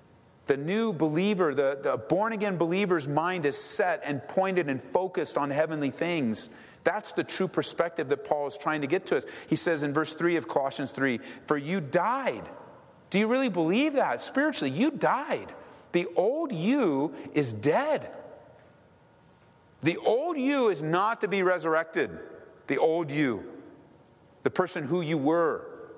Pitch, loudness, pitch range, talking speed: 170 Hz, -28 LUFS, 150-195 Hz, 160 wpm